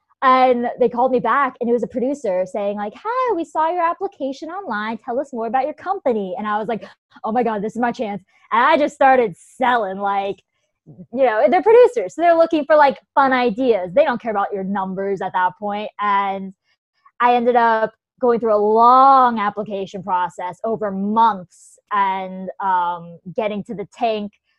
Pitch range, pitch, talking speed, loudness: 200-270 Hz, 230 Hz, 195 wpm, -18 LUFS